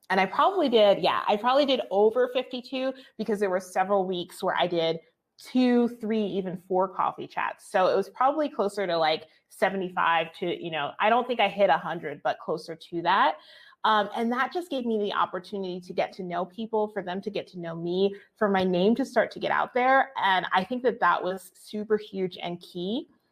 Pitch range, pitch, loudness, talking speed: 180-235 Hz, 200 Hz, -26 LUFS, 225 wpm